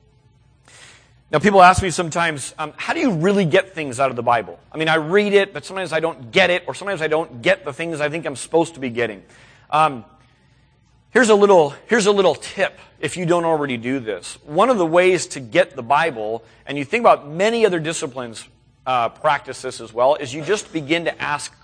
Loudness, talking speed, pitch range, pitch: -19 LUFS, 235 wpm, 125-175 Hz, 150 Hz